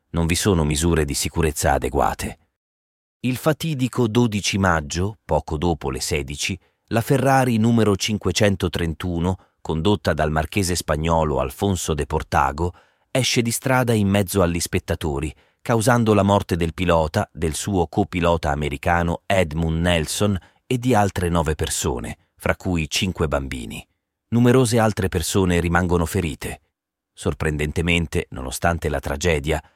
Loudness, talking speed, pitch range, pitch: -21 LUFS, 125 wpm, 80-100 Hz, 85 Hz